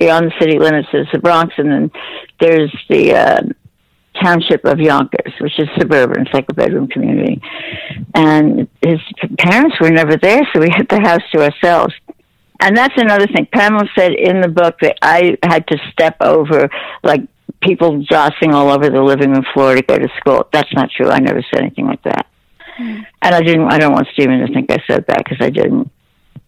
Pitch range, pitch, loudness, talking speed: 155-190 Hz, 165 Hz, -12 LUFS, 200 wpm